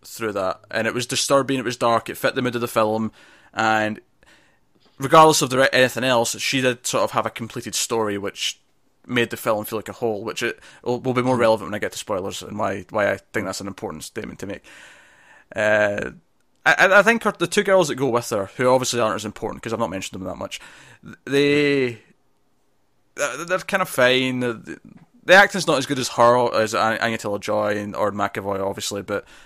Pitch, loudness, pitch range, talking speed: 120 Hz, -20 LUFS, 110-135 Hz, 220 wpm